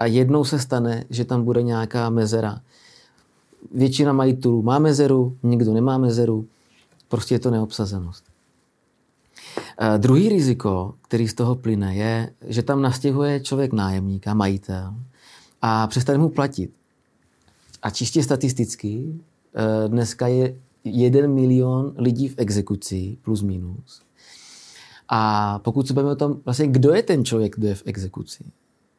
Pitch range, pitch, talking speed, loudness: 110-130 Hz, 120 Hz, 135 wpm, -21 LUFS